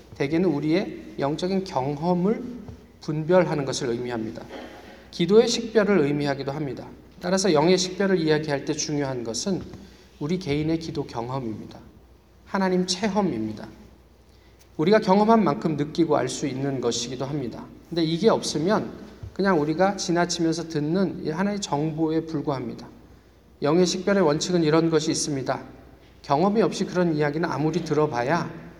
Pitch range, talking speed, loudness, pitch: 140-185 Hz, 335 characters per minute, -24 LUFS, 160 Hz